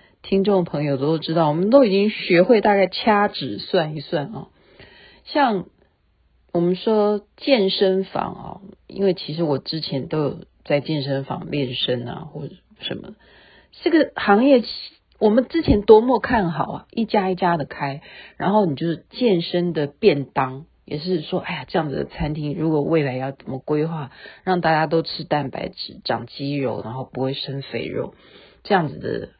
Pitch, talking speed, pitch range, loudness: 170 Hz, 245 characters per minute, 145-195 Hz, -21 LUFS